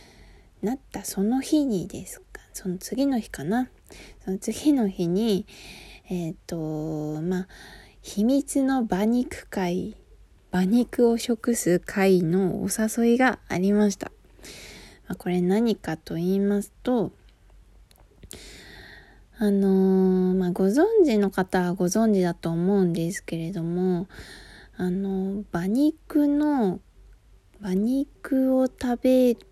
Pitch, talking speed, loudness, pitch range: 200 Hz, 200 characters per minute, -24 LUFS, 180-240 Hz